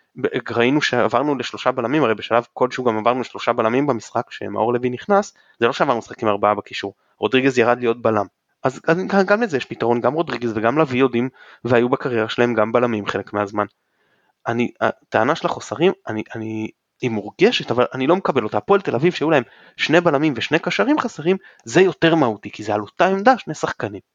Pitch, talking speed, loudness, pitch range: 125 Hz, 185 wpm, -19 LUFS, 110-160 Hz